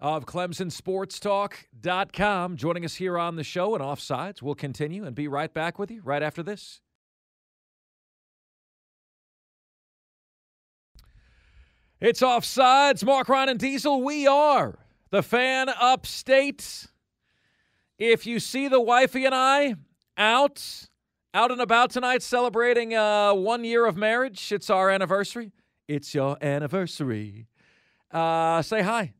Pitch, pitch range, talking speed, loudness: 200 Hz, 155-245 Hz, 125 wpm, -24 LUFS